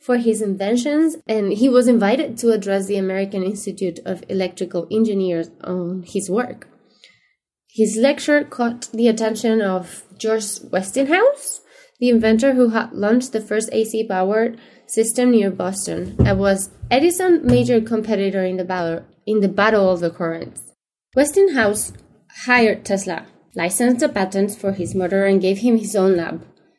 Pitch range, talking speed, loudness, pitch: 190-245 Hz, 150 wpm, -19 LUFS, 215 Hz